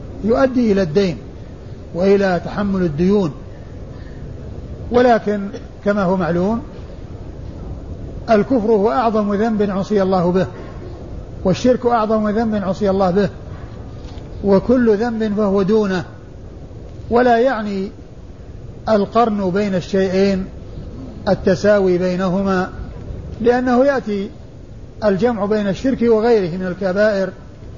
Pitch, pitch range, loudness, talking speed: 195 Hz, 180-220 Hz, -17 LUFS, 90 wpm